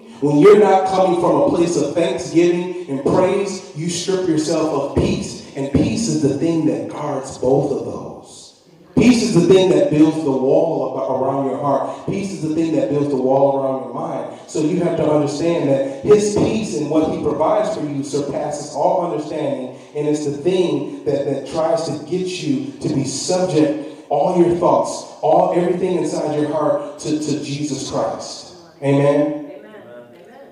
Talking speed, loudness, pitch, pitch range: 180 wpm, -18 LUFS, 155 Hz, 145-180 Hz